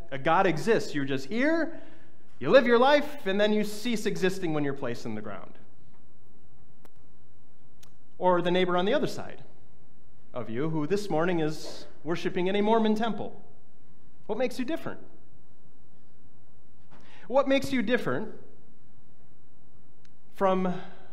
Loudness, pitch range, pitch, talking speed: -27 LUFS, 165-240 Hz, 195 Hz, 135 wpm